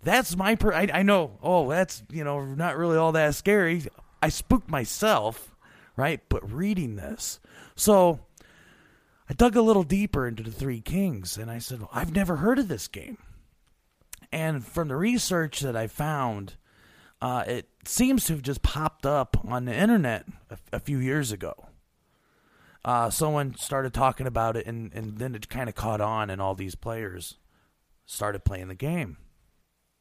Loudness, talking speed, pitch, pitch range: -26 LUFS, 175 wpm, 135 Hz, 110-175 Hz